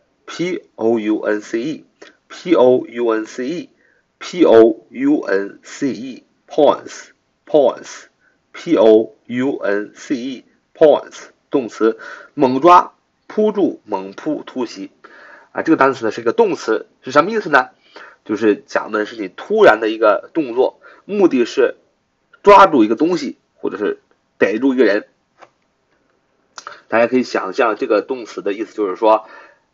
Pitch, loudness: 265 Hz, -16 LUFS